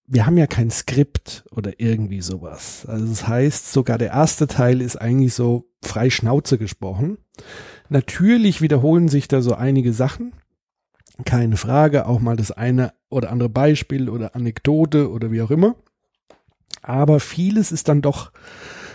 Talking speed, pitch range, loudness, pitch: 150 wpm, 115-145 Hz, -19 LUFS, 125 Hz